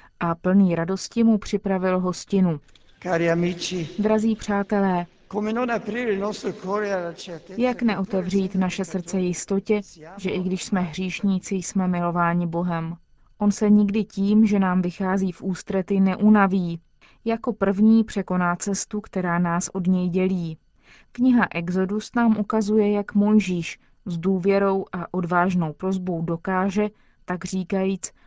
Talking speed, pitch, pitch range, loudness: 115 wpm, 190 Hz, 175-205 Hz, -23 LUFS